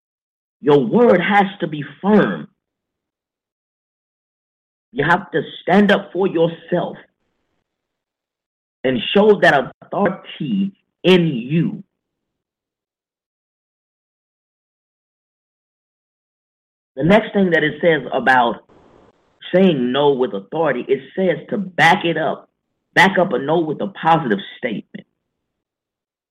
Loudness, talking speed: -17 LUFS, 100 wpm